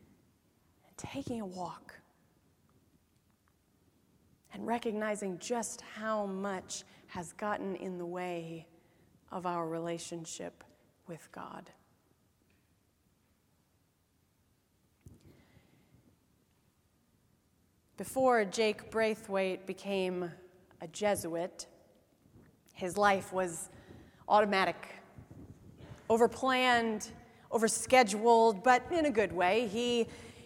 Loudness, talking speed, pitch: -32 LUFS, 70 wpm, 185 Hz